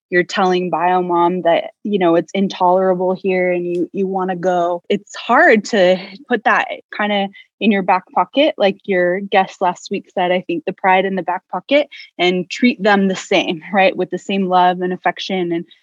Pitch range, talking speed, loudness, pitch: 180-200 Hz, 205 wpm, -16 LUFS, 185 Hz